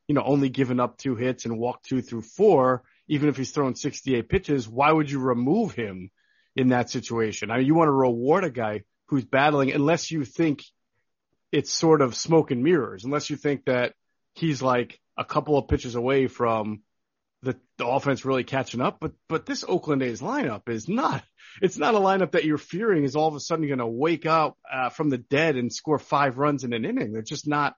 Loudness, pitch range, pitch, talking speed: -25 LUFS, 125-155 Hz, 140 Hz, 215 wpm